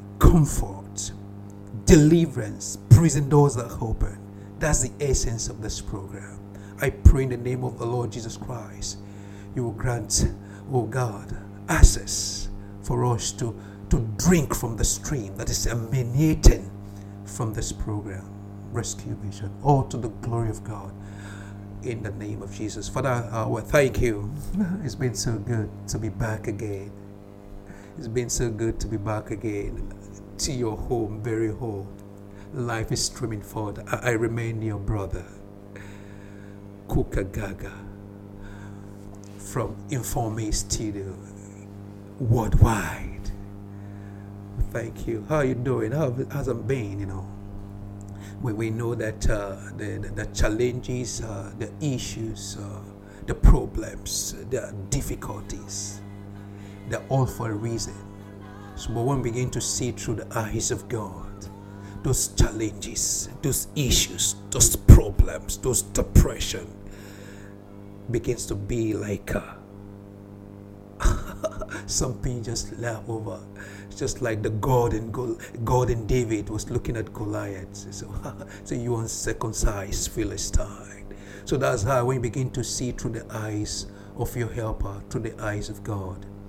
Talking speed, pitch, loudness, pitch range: 135 wpm, 105 Hz, -26 LUFS, 100-120 Hz